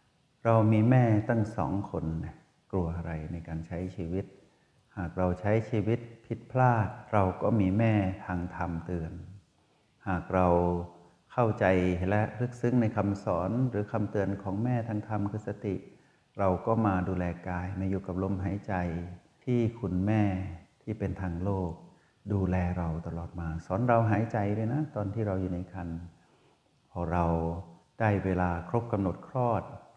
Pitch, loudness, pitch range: 95 Hz, -30 LUFS, 90-110 Hz